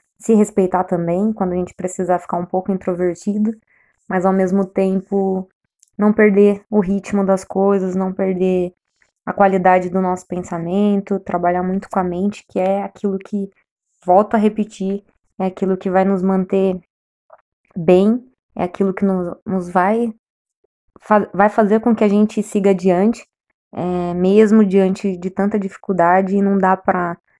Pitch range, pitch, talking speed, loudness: 185-205 Hz, 195 Hz, 155 wpm, -17 LUFS